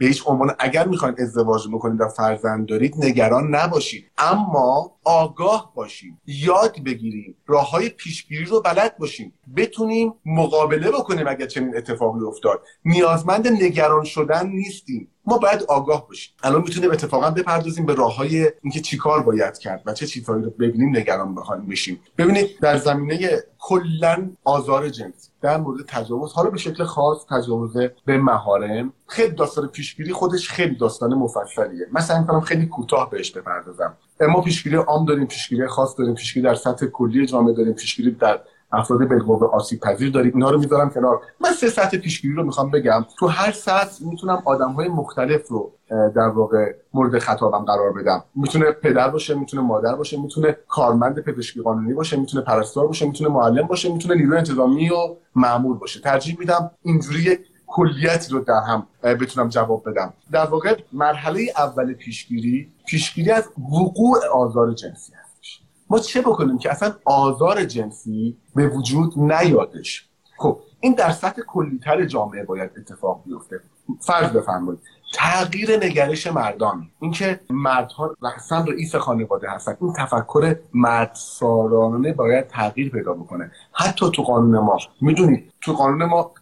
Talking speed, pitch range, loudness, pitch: 155 wpm, 120-170 Hz, -20 LUFS, 145 Hz